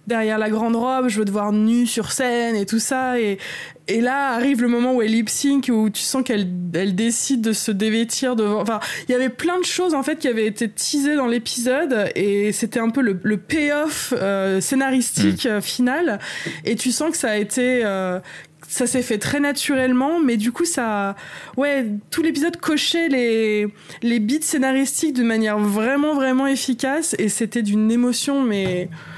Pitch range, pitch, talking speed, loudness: 215-270 Hz, 240 Hz, 195 wpm, -20 LUFS